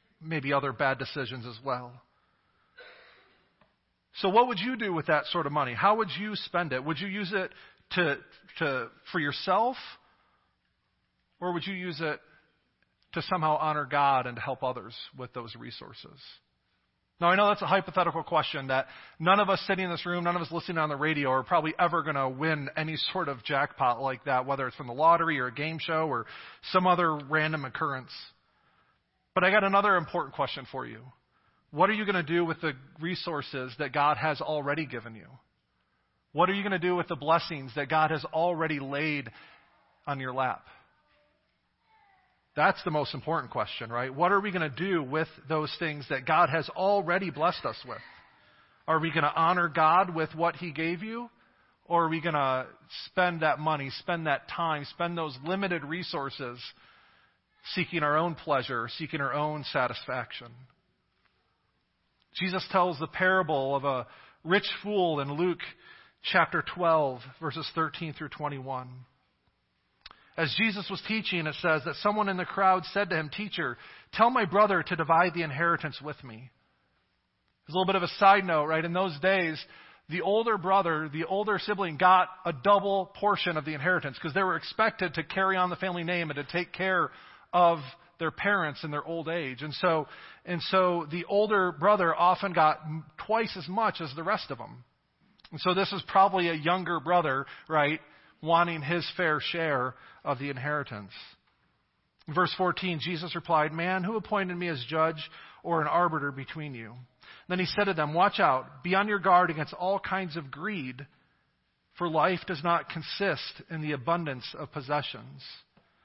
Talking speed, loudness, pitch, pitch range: 180 wpm, -28 LUFS, 165 Hz, 145-185 Hz